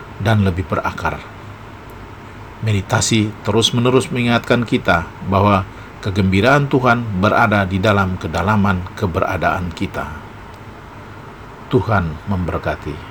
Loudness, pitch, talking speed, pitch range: -17 LUFS, 105 Hz, 85 wpm, 95-115 Hz